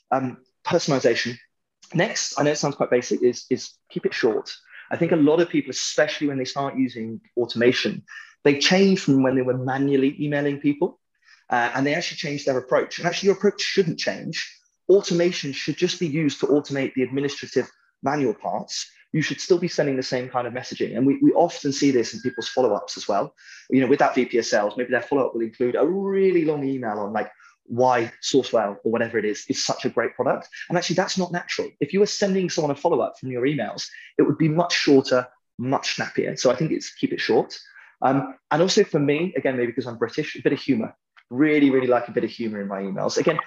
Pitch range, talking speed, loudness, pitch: 125-170 Hz, 220 wpm, -23 LUFS, 140 Hz